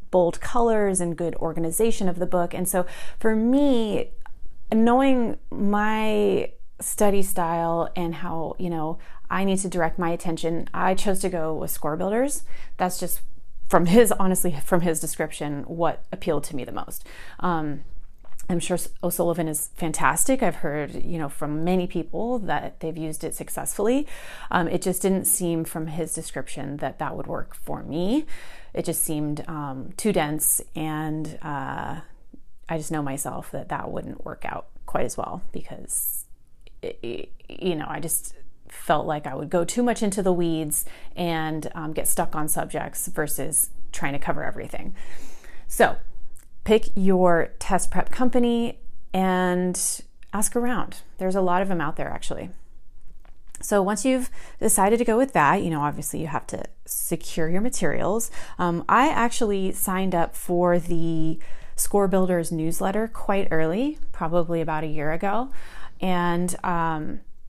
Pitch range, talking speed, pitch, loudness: 160-200 Hz, 160 wpm, 175 Hz, -25 LUFS